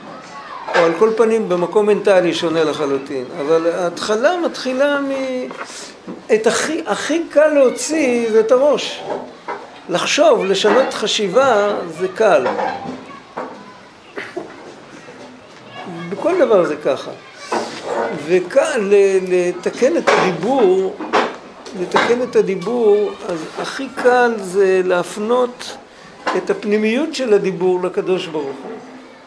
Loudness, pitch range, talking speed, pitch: -16 LUFS, 185-260 Hz, 100 wpm, 215 Hz